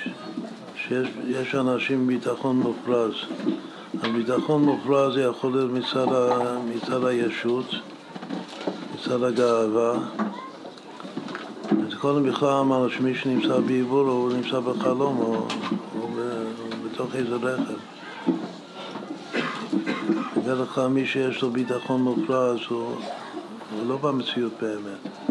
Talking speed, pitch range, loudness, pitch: 100 wpm, 120-130 Hz, -25 LUFS, 125 Hz